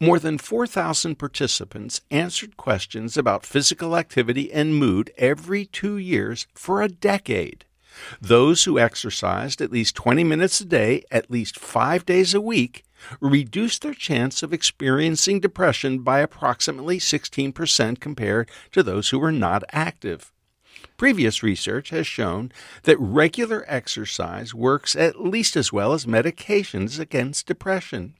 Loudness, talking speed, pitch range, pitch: -21 LUFS, 135 wpm, 125-180 Hz, 150 Hz